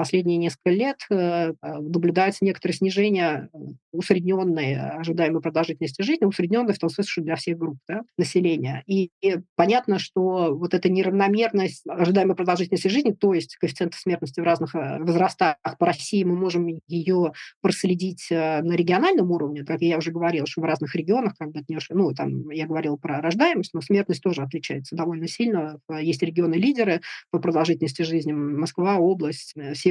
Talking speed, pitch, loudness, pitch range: 160 wpm, 170 Hz, -23 LUFS, 160-185 Hz